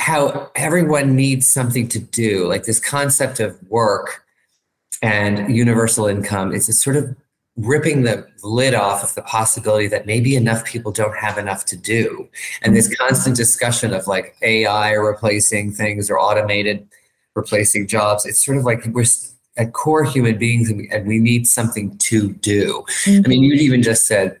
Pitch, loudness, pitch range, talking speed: 115 Hz, -16 LUFS, 105-125 Hz, 165 wpm